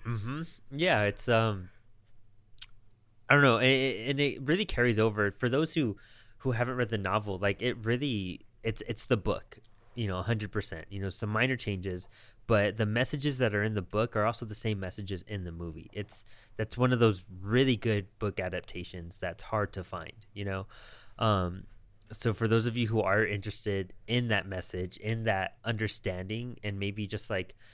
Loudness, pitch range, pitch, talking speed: -31 LUFS, 100-115 Hz, 110 Hz, 190 wpm